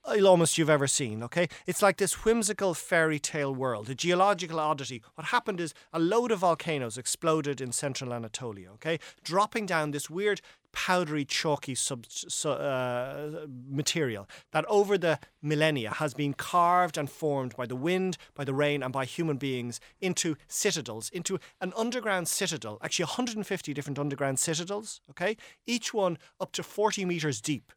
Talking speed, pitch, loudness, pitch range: 160 wpm, 155 Hz, -29 LUFS, 140-185 Hz